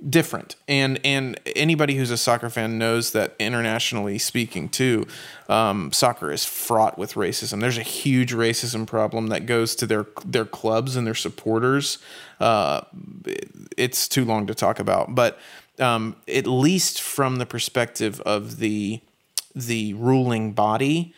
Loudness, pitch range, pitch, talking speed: -22 LUFS, 110-130 Hz, 120 Hz, 145 wpm